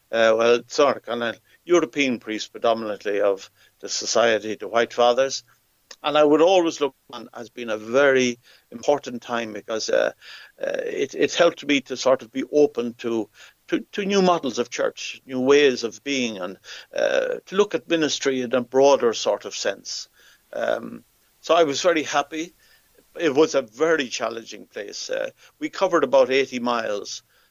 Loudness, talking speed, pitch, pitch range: -22 LUFS, 170 wpm, 135 Hz, 120-170 Hz